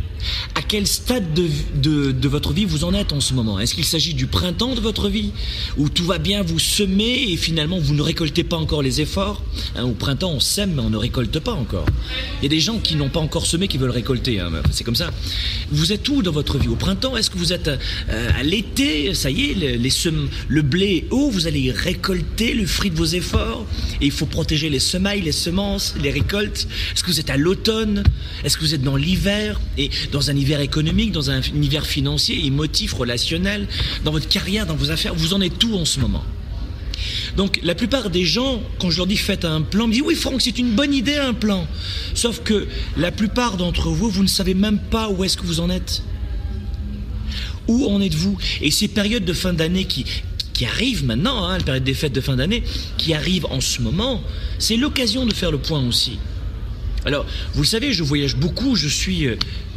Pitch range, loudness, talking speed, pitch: 125-200 Hz, -20 LUFS, 225 wpm, 155 Hz